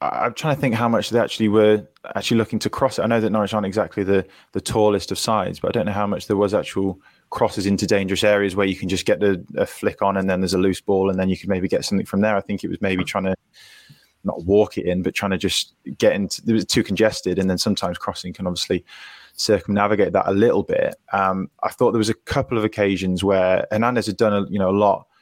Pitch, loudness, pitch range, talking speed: 100 Hz, -21 LUFS, 95-110 Hz, 265 wpm